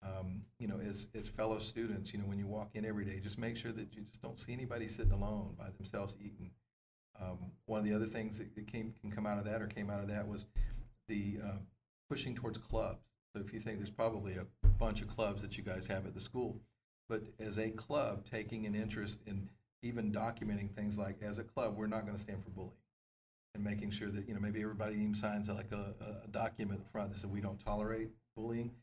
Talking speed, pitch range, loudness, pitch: 235 wpm, 100-110 Hz, -42 LUFS, 105 Hz